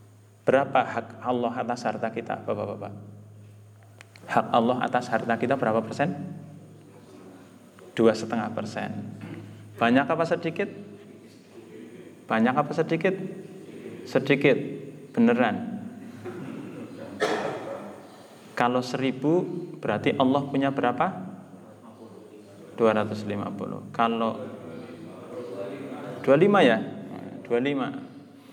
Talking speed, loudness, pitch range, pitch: 75 wpm, -26 LUFS, 110-165 Hz, 125 Hz